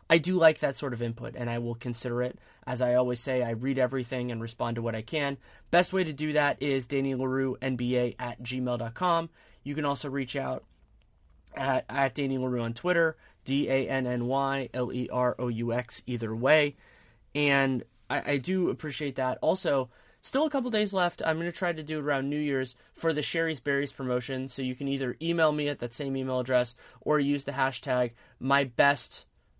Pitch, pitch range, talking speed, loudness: 135 Hz, 125-145 Hz, 185 wpm, -29 LUFS